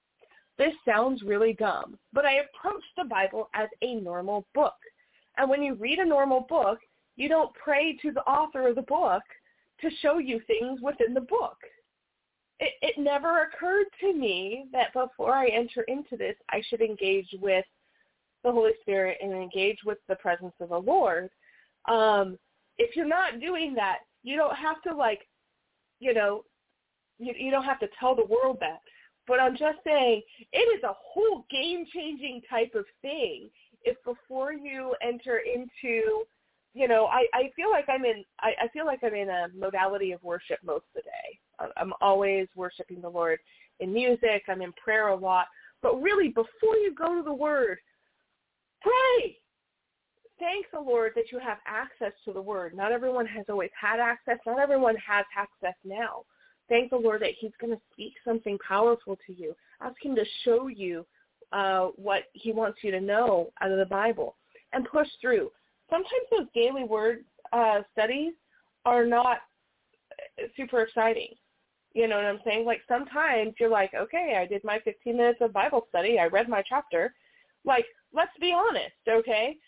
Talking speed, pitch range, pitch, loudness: 175 wpm, 210-300 Hz, 240 Hz, -28 LUFS